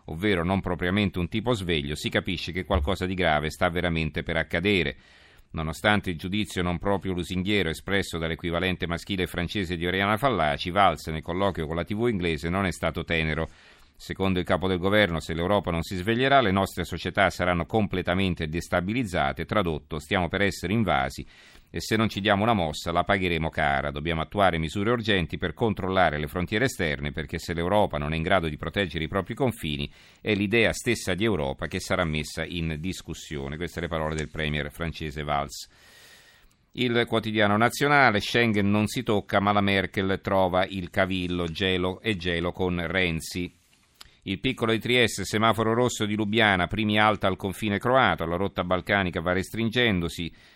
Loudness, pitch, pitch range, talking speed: -26 LUFS, 90 Hz, 85-105 Hz, 175 wpm